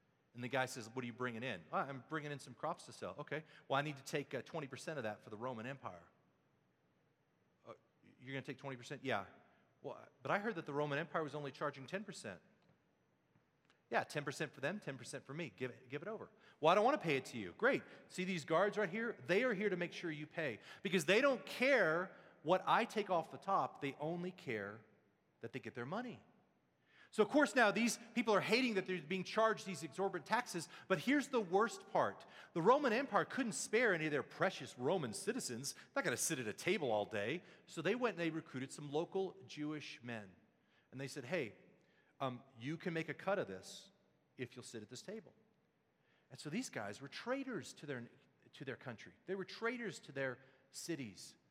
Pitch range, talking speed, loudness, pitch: 130-190 Hz, 220 wpm, -40 LUFS, 150 Hz